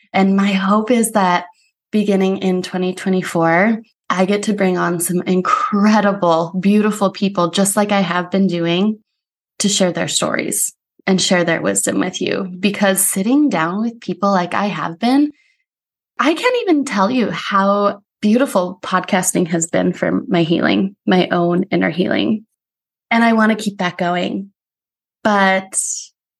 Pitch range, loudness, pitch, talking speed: 180-210 Hz, -16 LUFS, 195 Hz, 150 wpm